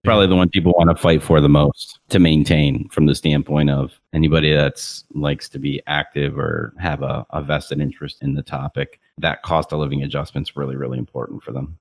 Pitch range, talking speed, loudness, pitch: 70-80 Hz, 210 wpm, -18 LUFS, 75 Hz